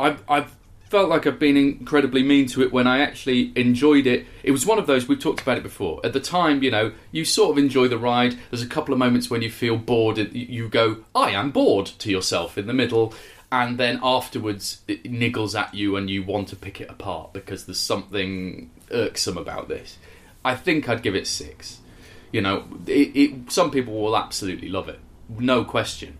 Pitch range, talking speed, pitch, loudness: 105-140 Hz, 215 wpm, 120 Hz, -22 LUFS